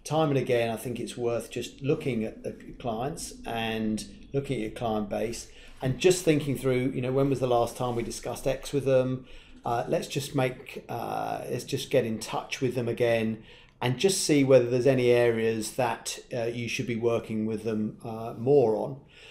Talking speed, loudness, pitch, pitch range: 200 wpm, -28 LUFS, 120 Hz, 115-135 Hz